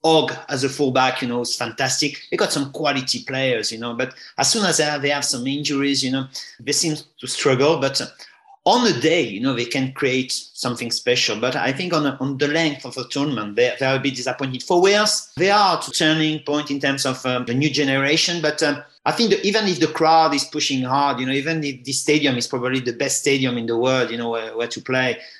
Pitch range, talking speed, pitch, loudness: 130-155 Hz, 245 wpm, 140 Hz, -20 LUFS